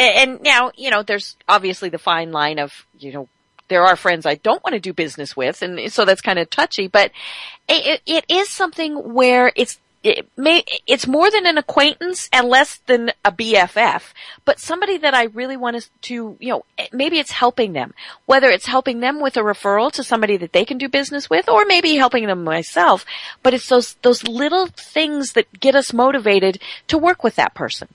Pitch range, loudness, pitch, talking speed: 205-290 Hz, -16 LUFS, 250 Hz, 205 wpm